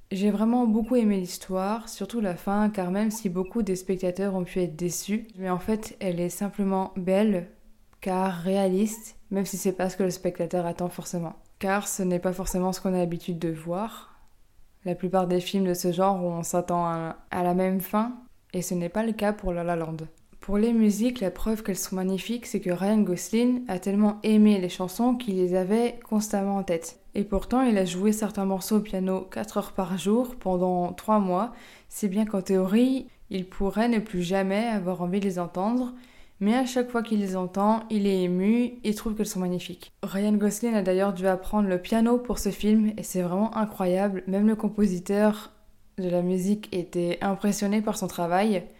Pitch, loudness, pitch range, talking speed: 195 Hz, -26 LUFS, 180-215 Hz, 205 wpm